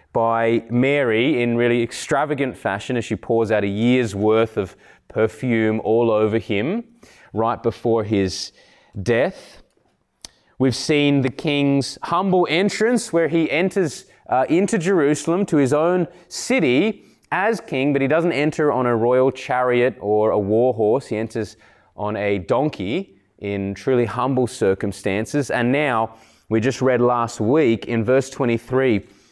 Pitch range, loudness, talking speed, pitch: 110-145 Hz, -20 LUFS, 145 wpm, 125 Hz